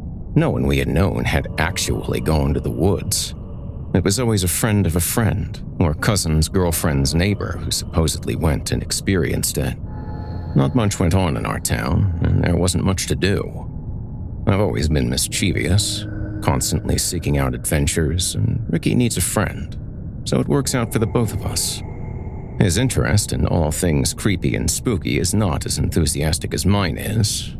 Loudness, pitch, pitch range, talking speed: -20 LUFS, 90 Hz, 80-105 Hz, 175 wpm